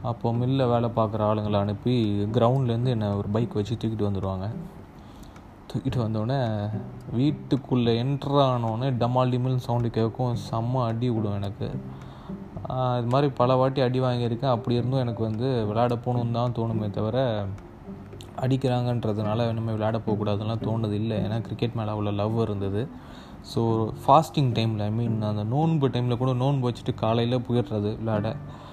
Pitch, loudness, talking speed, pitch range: 115 Hz, -26 LUFS, 135 wpm, 105-125 Hz